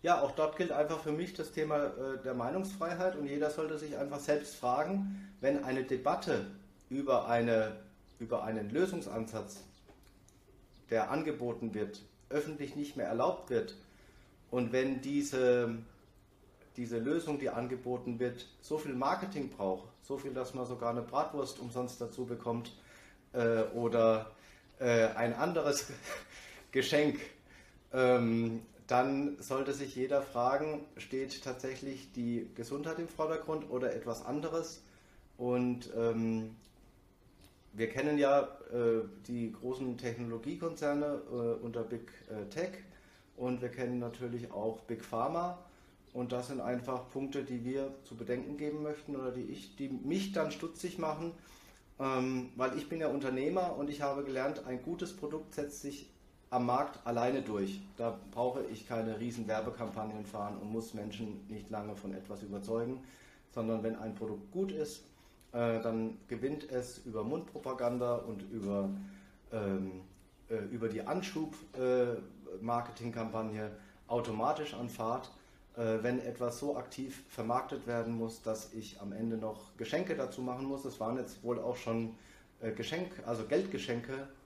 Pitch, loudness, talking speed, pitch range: 125 Hz, -37 LUFS, 145 wpm, 110-140 Hz